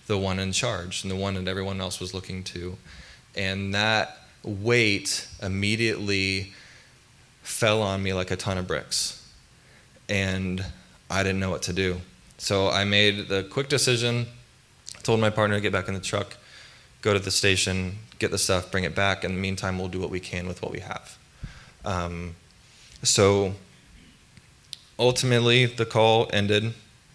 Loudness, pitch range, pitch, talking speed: -25 LUFS, 95-110 Hz, 100 Hz, 170 wpm